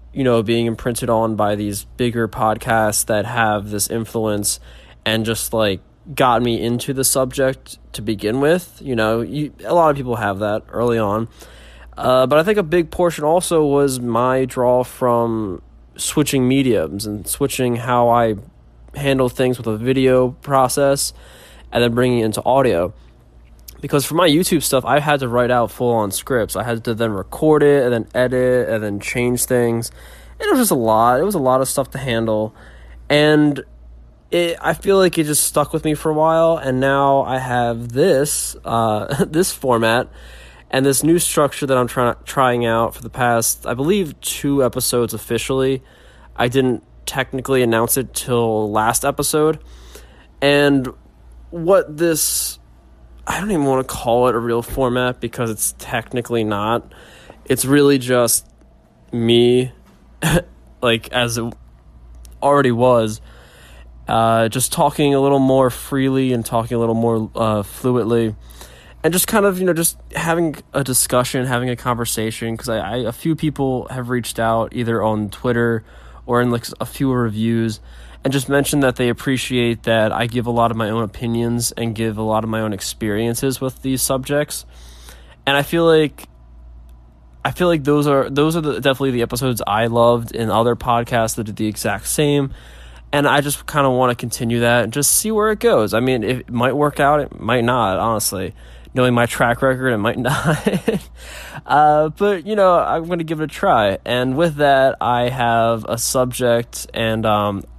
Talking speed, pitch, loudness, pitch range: 180 wpm, 120 Hz, -18 LUFS, 110-135 Hz